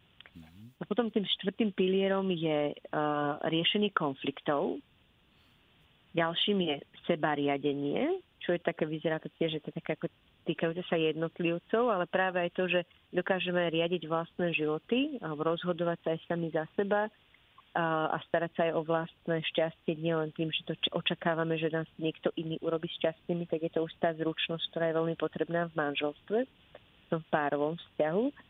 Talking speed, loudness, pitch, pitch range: 165 wpm, -32 LUFS, 165 Hz, 160-180 Hz